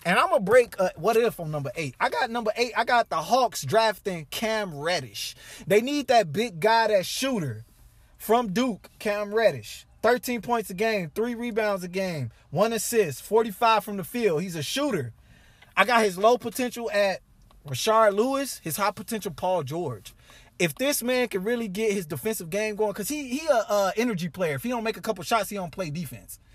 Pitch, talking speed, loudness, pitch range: 210 Hz, 205 wpm, -25 LUFS, 175-230 Hz